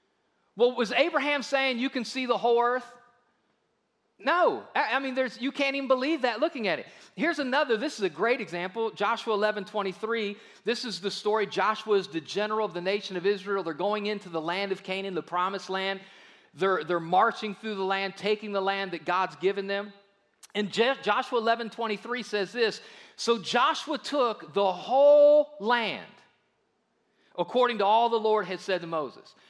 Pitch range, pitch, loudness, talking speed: 195-245 Hz, 215 Hz, -27 LUFS, 185 wpm